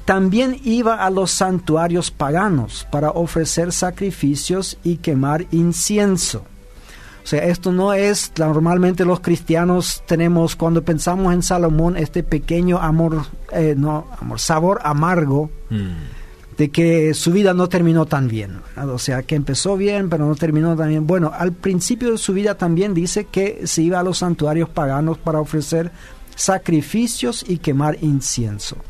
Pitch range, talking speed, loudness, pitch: 150-185 Hz, 150 wpm, -18 LUFS, 165 Hz